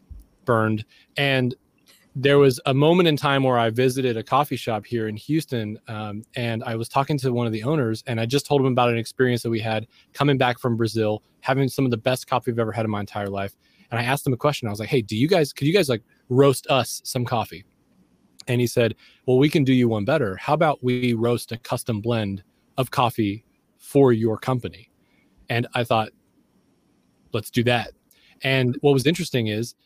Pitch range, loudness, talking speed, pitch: 115-135 Hz, -22 LUFS, 220 wpm, 125 Hz